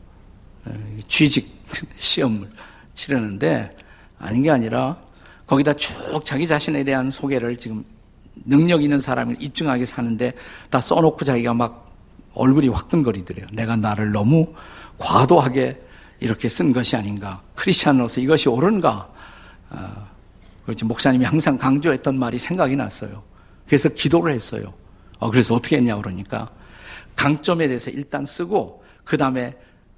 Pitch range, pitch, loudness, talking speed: 105-145 Hz, 125 Hz, -19 LUFS, 300 characters per minute